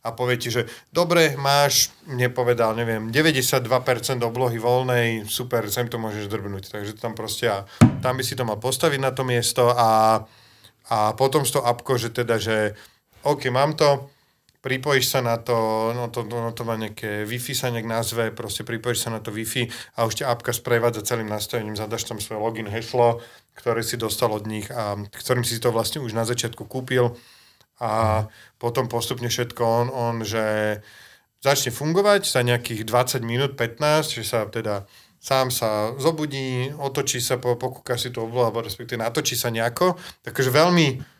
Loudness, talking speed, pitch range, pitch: -23 LUFS, 170 wpm, 115-130 Hz, 120 Hz